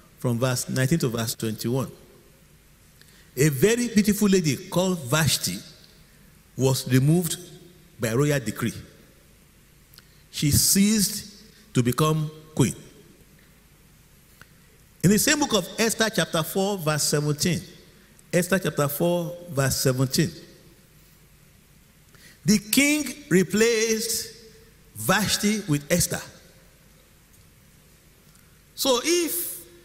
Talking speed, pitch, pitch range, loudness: 90 wpm, 175 Hz, 145-200 Hz, -23 LUFS